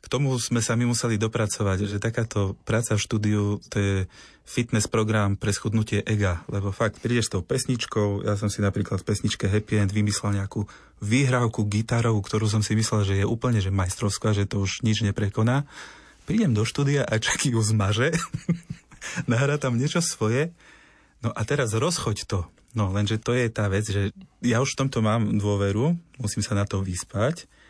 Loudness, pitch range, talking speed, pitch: -25 LUFS, 105-120 Hz, 185 wpm, 110 Hz